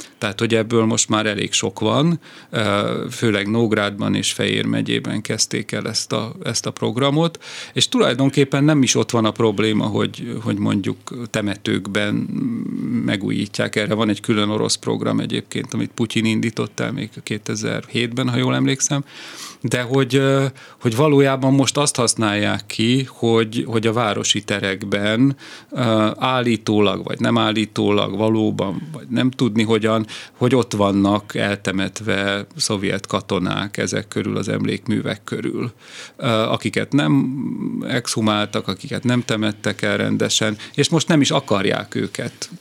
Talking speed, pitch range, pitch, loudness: 135 wpm, 105-130 Hz, 115 Hz, -19 LUFS